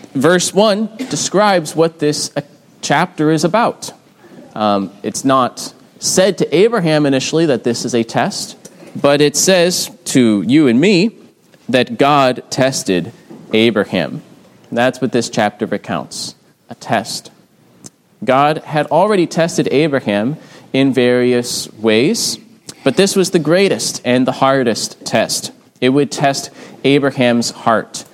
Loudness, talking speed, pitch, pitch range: -14 LUFS, 130 wpm, 150 Hz, 125-180 Hz